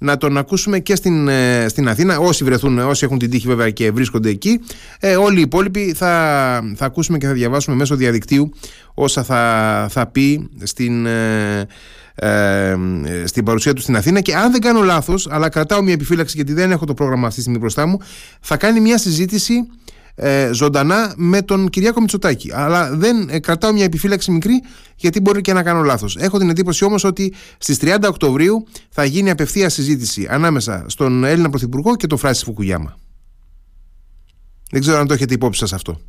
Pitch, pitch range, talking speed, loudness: 145 Hz, 120-185 Hz, 180 wpm, -15 LUFS